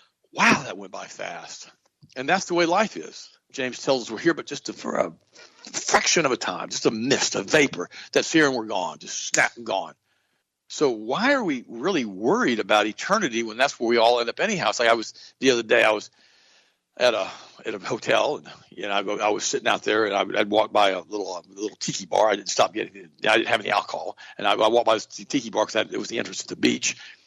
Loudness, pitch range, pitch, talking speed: -23 LUFS, 115-170 Hz, 120 Hz, 250 wpm